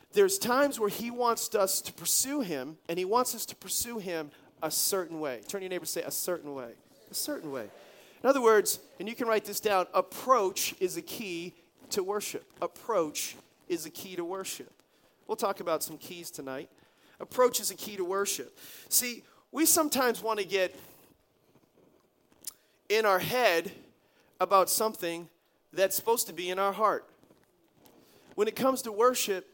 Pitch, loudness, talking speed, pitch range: 200 Hz, -30 LUFS, 175 wpm, 180-245 Hz